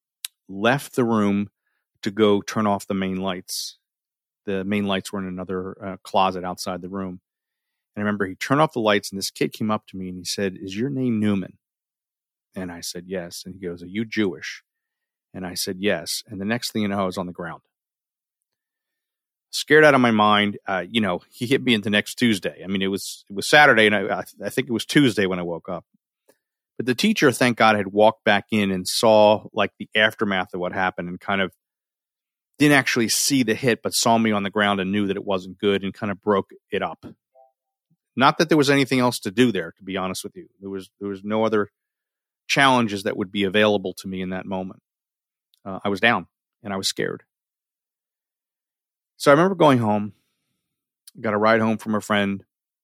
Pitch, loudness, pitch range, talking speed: 105 Hz, -21 LUFS, 95-115 Hz, 220 wpm